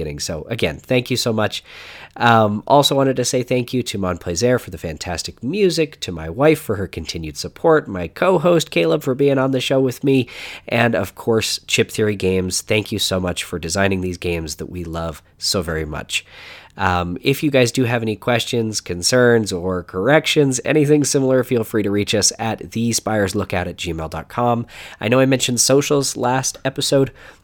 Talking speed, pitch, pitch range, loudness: 190 wpm, 110 Hz, 90-130 Hz, -18 LUFS